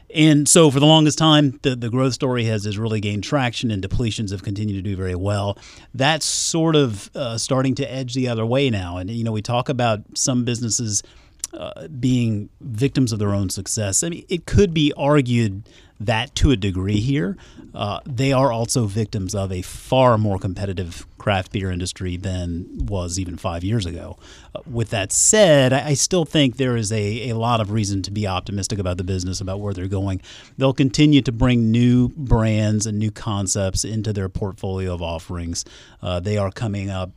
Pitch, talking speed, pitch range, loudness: 110 Hz, 200 wpm, 95-130 Hz, -20 LUFS